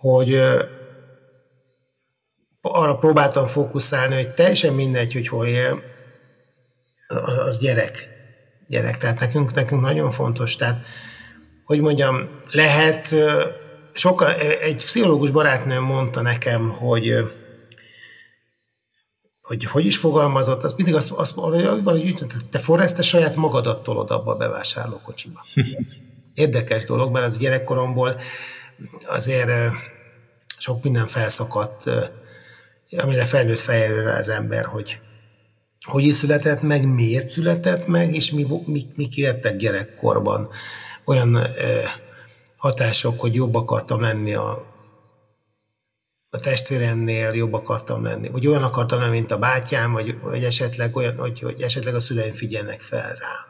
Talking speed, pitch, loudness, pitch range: 120 wpm, 130 Hz, -20 LUFS, 120-145 Hz